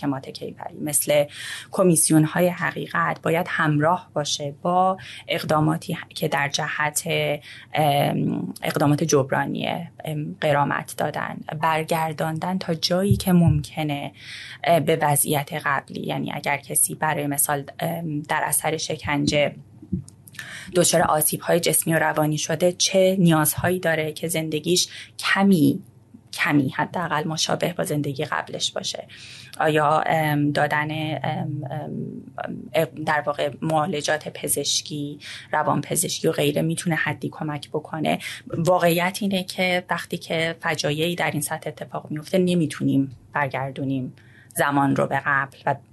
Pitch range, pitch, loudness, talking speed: 145-170 Hz, 155 Hz, -22 LUFS, 110 wpm